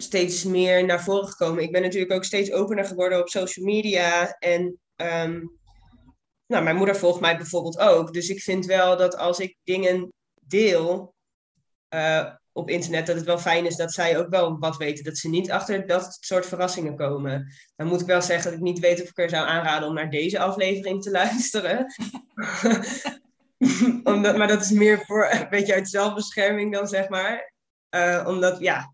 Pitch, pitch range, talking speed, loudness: 180 Hz, 170-200 Hz, 190 wpm, -23 LUFS